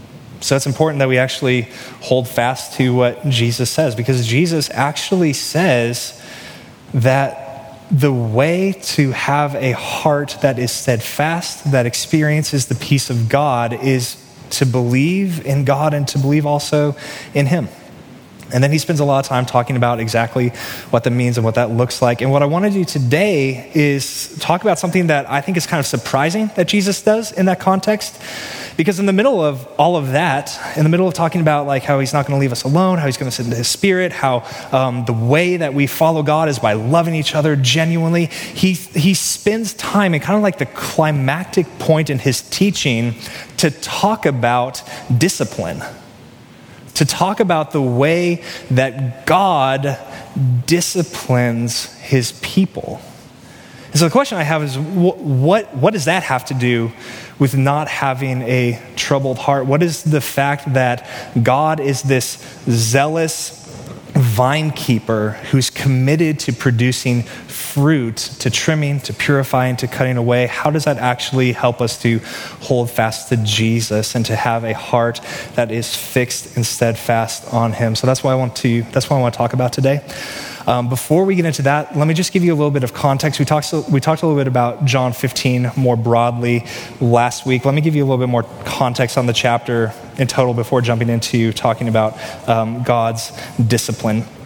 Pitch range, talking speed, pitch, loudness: 120-155 Hz, 185 wpm, 135 Hz, -16 LUFS